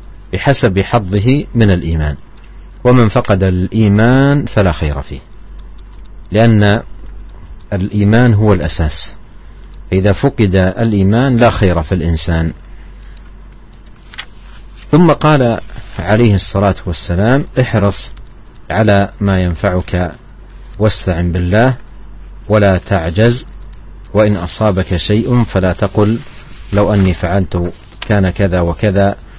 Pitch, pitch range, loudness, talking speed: 100 Hz, 90-115 Hz, -13 LUFS, 90 wpm